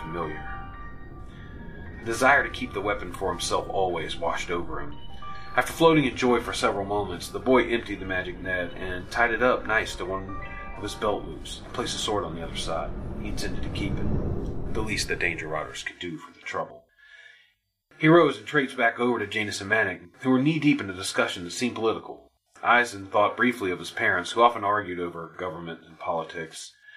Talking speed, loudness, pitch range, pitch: 205 wpm, -26 LUFS, 85-125 Hz, 100 Hz